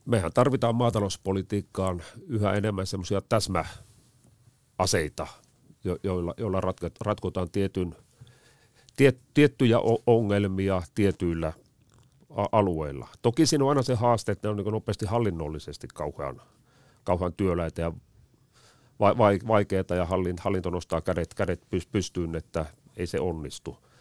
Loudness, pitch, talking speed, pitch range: -27 LUFS, 100 Hz, 100 wpm, 90-120 Hz